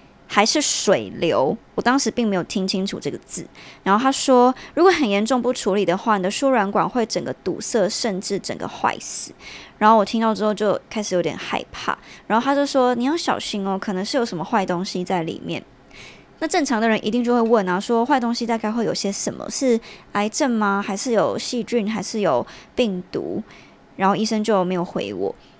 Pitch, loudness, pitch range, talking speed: 215 Hz, -21 LUFS, 195-240 Hz, 300 characters per minute